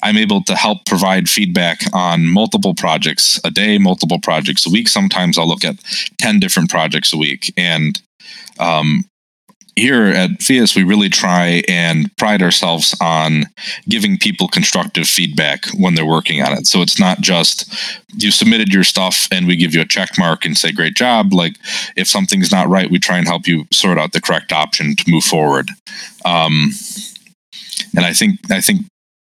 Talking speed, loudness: 180 wpm, -13 LUFS